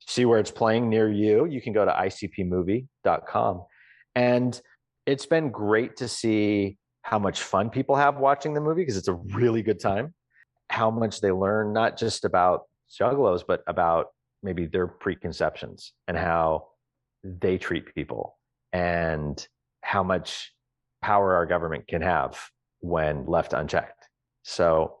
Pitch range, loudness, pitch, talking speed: 95-125 Hz, -25 LUFS, 110 Hz, 145 wpm